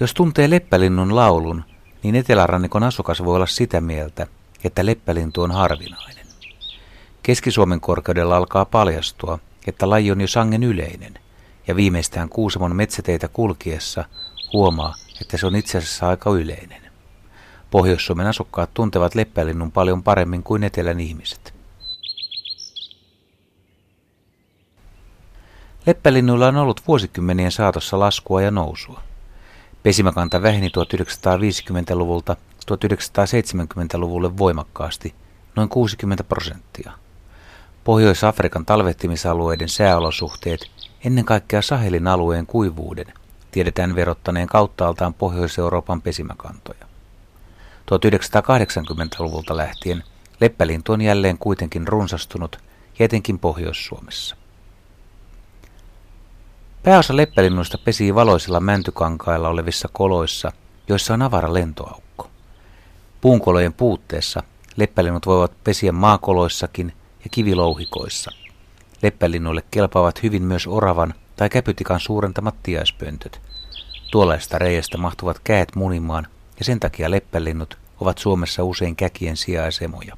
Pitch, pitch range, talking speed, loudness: 95 Hz, 85-105 Hz, 95 wpm, -19 LUFS